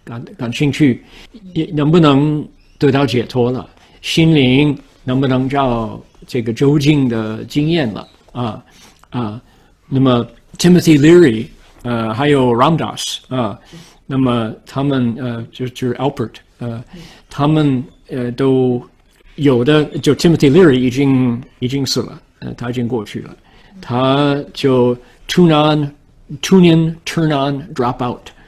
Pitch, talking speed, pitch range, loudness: 135 Hz, 275 characters per minute, 120-150 Hz, -15 LUFS